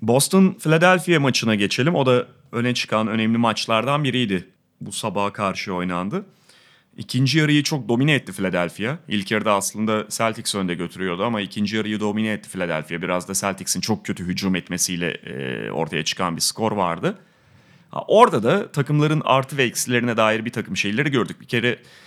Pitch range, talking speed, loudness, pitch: 95-130 Hz, 160 wpm, -21 LUFS, 110 Hz